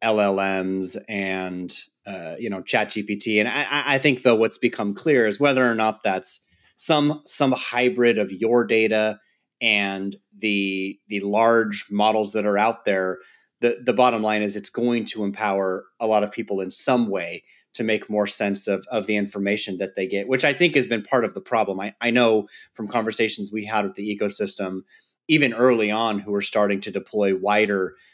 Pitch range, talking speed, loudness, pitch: 100-115 Hz, 190 wpm, -22 LUFS, 105 Hz